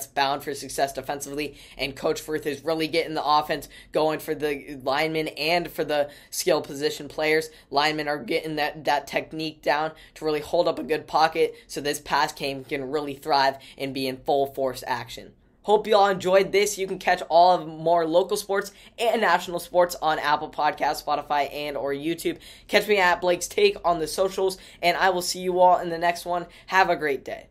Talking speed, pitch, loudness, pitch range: 205 wpm, 155 Hz, -24 LUFS, 145-180 Hz